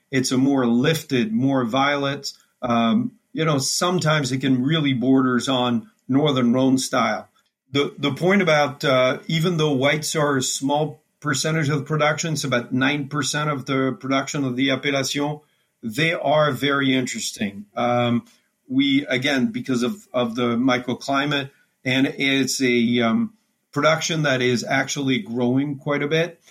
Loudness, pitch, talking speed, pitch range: -21 LUFS, 140 Hz, 150 wpm, 130-155 Hz